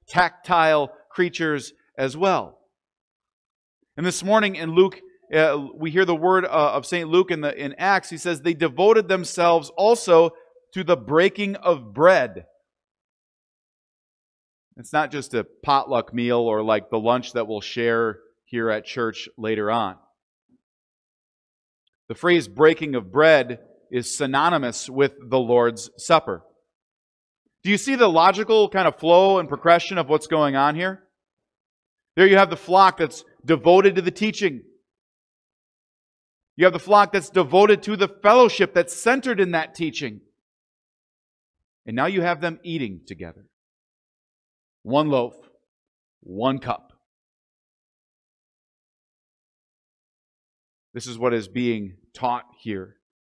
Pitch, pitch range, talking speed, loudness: 145 Hz, 110-180 Hz, 135 wpm, -20 LUFS